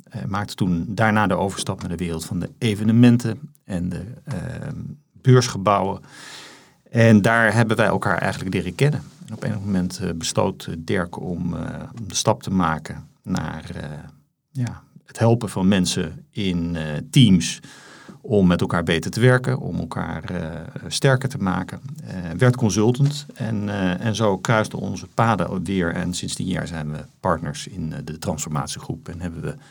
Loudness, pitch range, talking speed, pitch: -22 LUFS, 90-125 Hz, 170 wpm, 105 Hz